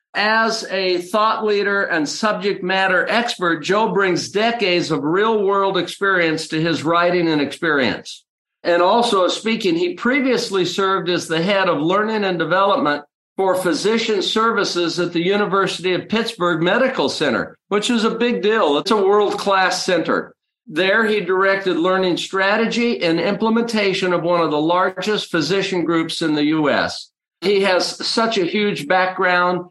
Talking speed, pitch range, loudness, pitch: 155 wpm, 175-215 Hz, -18 LUFS, 190 Hz